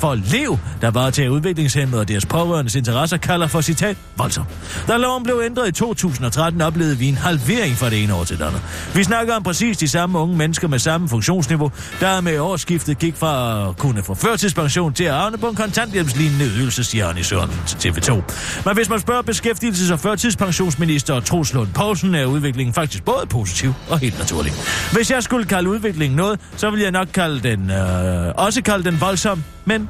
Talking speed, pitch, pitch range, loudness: 195 wpm, 165 Hz, 125-195 Hz, -18 LUFS